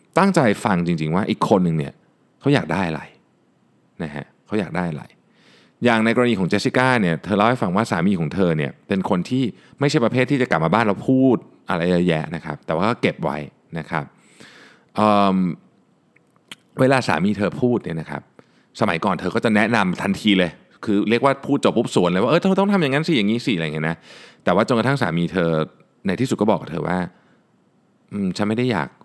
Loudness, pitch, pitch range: -20 LUFS, 100 Hz, 85-125 Hz